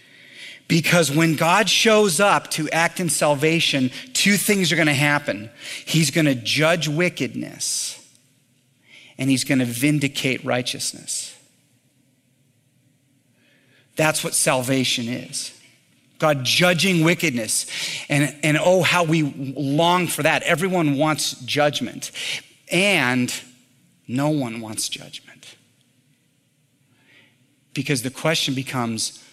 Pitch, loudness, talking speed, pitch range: 140 Hz, -20 LUFS, 110 wpm, 130-160 Hz